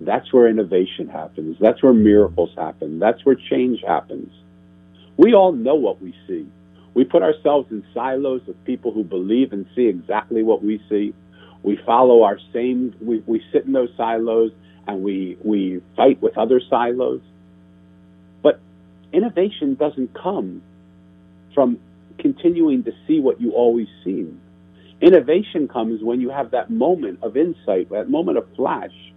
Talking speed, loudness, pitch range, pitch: 155 wpm, -19 LUFS, 95-125 Hz, 110 Hz